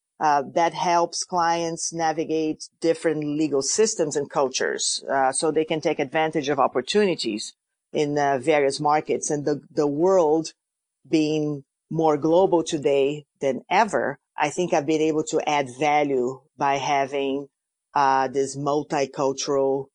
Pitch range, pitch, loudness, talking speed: 140-160 Hz, 150 Hz, -23 LUFS, 135 wpm